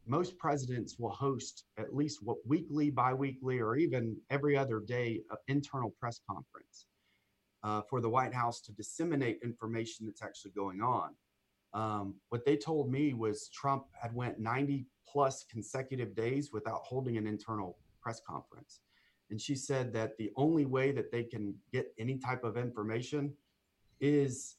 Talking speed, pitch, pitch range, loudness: 160 wpm, 120 Hz, 110-140 Hz, -36 LUFS